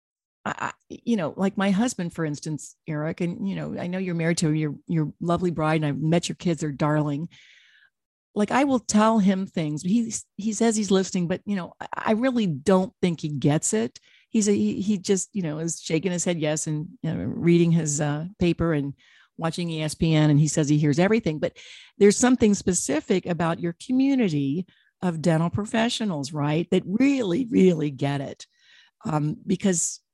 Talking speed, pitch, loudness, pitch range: 185 wpm, 175 Hz, -24 LUFS, 155-205 Hz